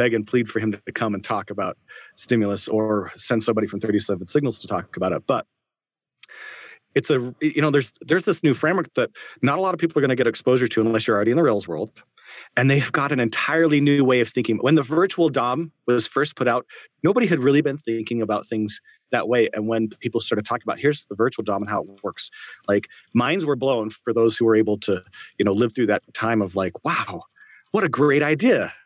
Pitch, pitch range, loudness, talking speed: 120 Hz, 110-145 Hz, -22 LUFS, 235 wpm